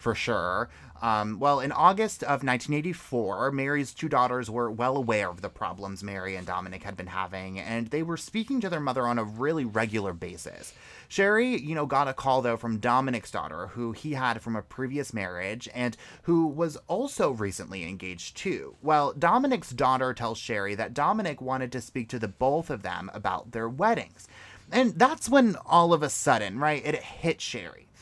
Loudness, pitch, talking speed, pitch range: -28 LUFS, 130 Hz, 190 wpm, 110-155 Hz